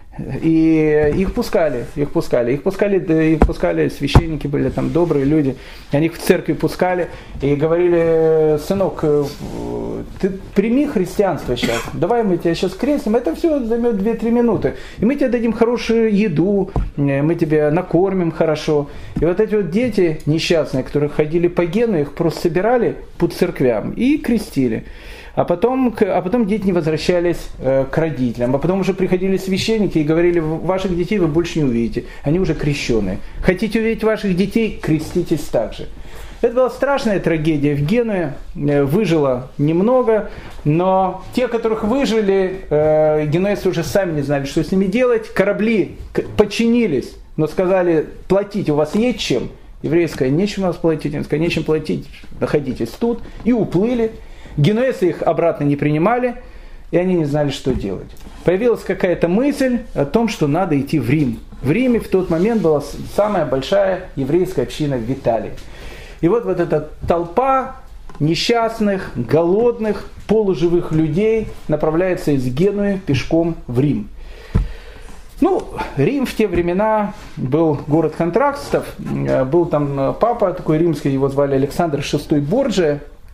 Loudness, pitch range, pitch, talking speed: -17 LUFS, 150-205 Hz, 170 Hz, 145 wpm